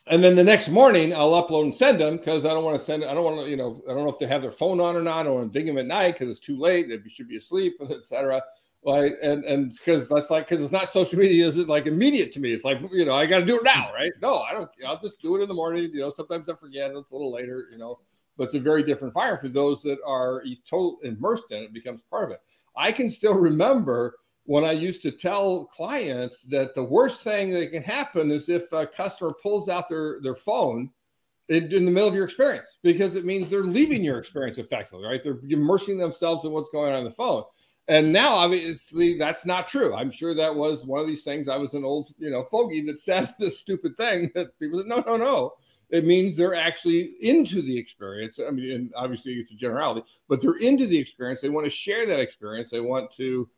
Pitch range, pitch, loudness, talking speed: 140-190 Hz, 160 Hz, -24 LUFS, 260 wpm